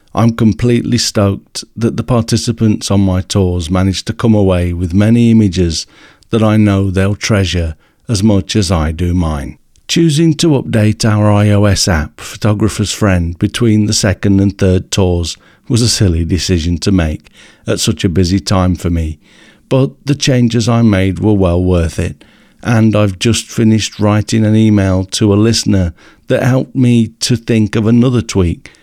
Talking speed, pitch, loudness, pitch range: 170 wpm, 105 Hz, -12 LUFS, 95-115 Hz